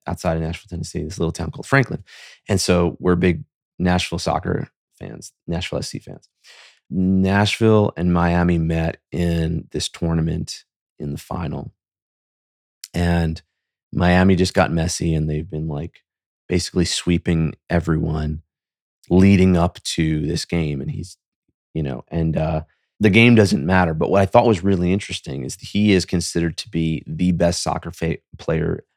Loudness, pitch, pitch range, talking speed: -20 LUFS, 85 Hz, 80-90 Hz, 155 wpm